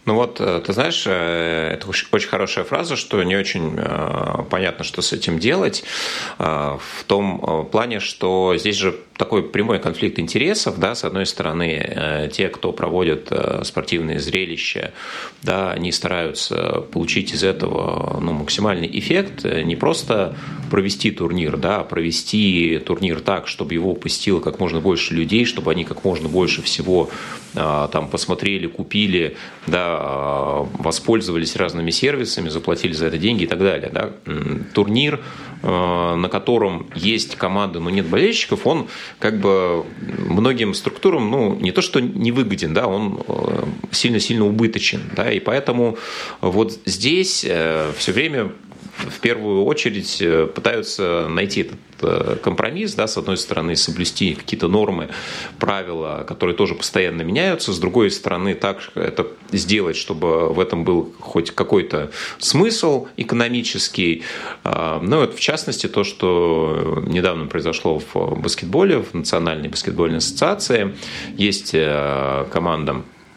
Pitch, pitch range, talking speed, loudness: 85 Hz, 80-105 Hz, 130 wpm, -20 LUFS